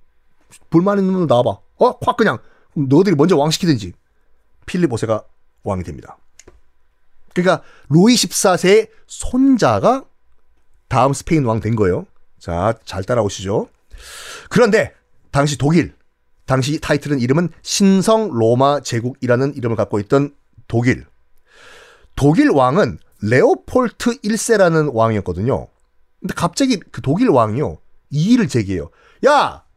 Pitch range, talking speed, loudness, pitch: 105-170 Hz, 265 characters per minute, -16 LUFS, 135 Hz